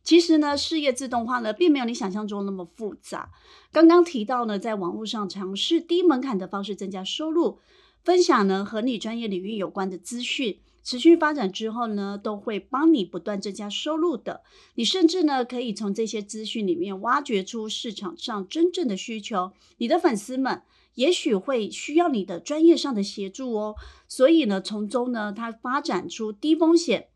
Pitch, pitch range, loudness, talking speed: 230 Hz, 205-310 Hz, -24 LUFS, 285 characters per minute